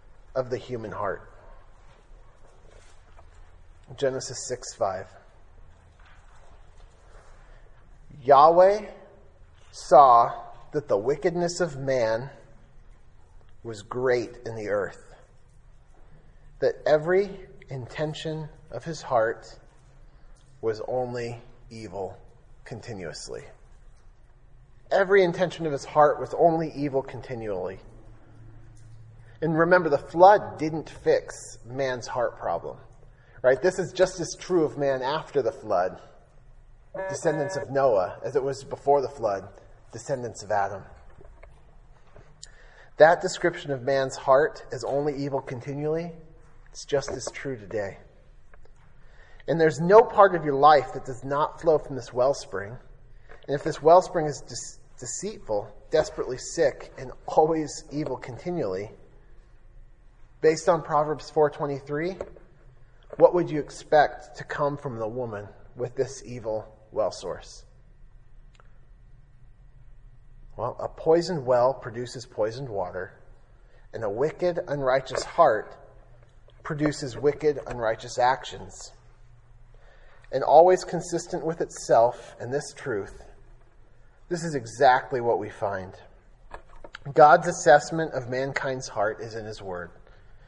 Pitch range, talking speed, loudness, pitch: 115-155 Hz, 110 wpm, -25 LUFS, 130 Hz